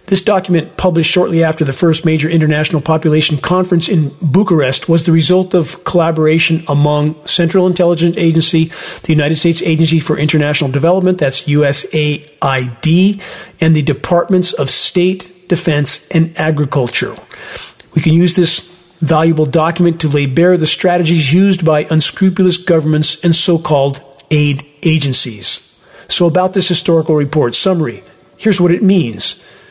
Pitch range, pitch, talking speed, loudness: 150-180 Hz, 165 Hz, 140 wpm, -12 LUFS